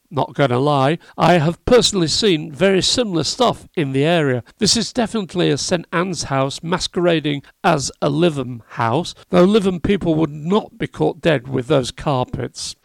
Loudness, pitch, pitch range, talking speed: -18 LUFS, 165 Hz, 145-185 Hz, 175 wpm